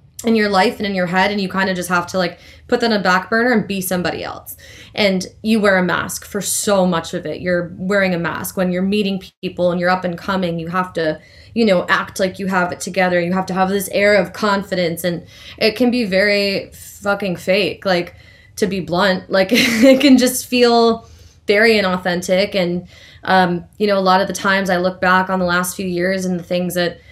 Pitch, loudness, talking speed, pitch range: 185 Hz, -17 LUFS, 235 wpm, 180-205 Hz